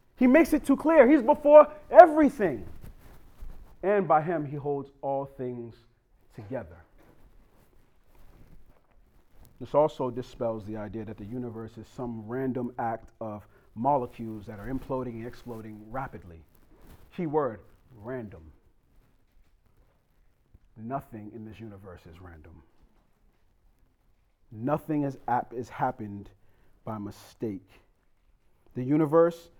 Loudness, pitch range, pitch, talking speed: -25 LUFS, 100-140 Hz, 115 Hz, 105 wpm